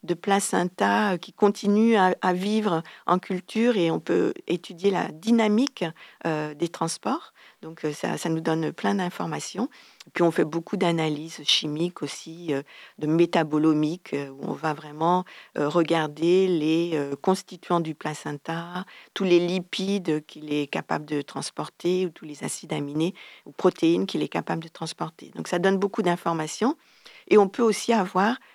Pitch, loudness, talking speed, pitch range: 170 Hz, -25 LUFS, 150 wpm, 155-190 Hz